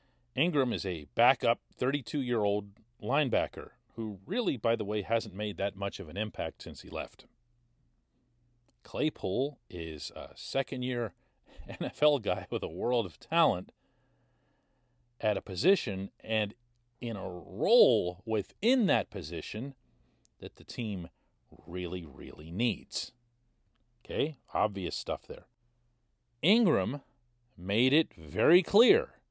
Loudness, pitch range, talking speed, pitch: -31 LUFS, 100-130 Hz, 125 wpm, 120 Hz